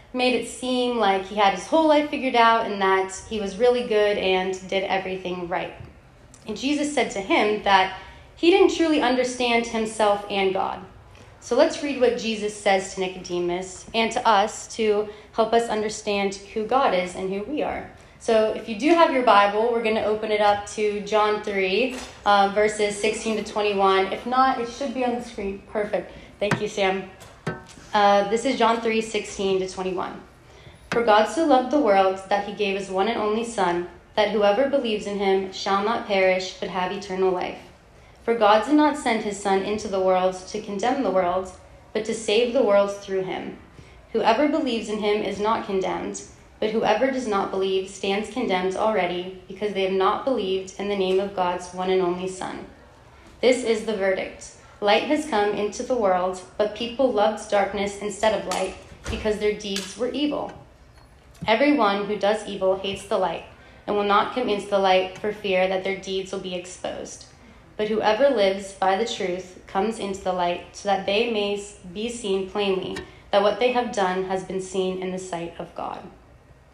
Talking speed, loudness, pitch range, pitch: 195 wpm, -23 LUFS, 190-225 Hz, 205 Hz